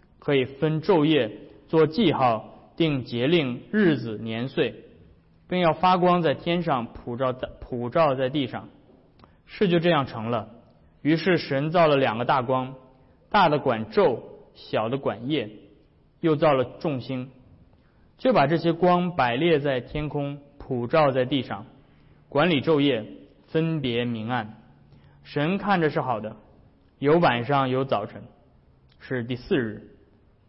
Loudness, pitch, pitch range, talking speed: -24 LUFS, 135 Hz, 120-160 Hz, 190 characters per minute